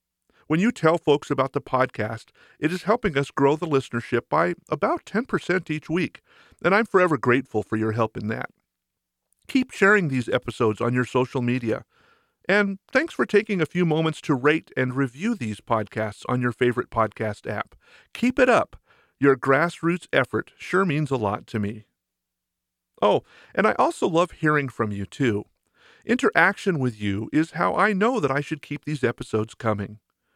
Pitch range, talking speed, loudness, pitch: 120-180 Hz, 175 wpm, -23 LUFS, 145 Hz